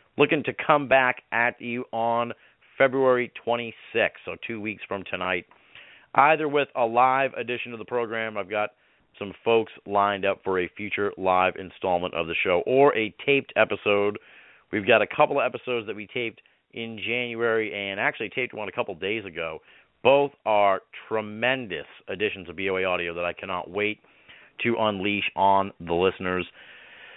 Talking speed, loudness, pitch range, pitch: 170 wpm, -25 LUFS, 100-125 Hz, 110 Hz